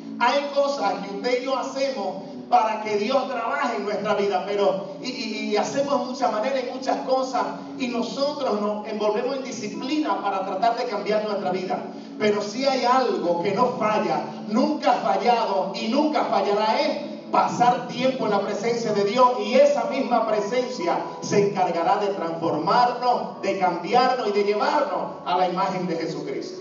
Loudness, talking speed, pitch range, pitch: -23 LUFS, 170 wpm, 200-255 Hz, 230 Hz